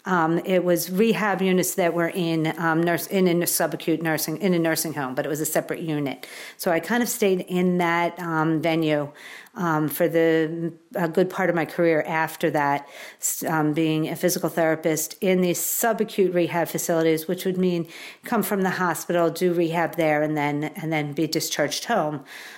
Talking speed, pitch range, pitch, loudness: 190 wpm, 160-180 Hz, 165 Hz, -23 LUFS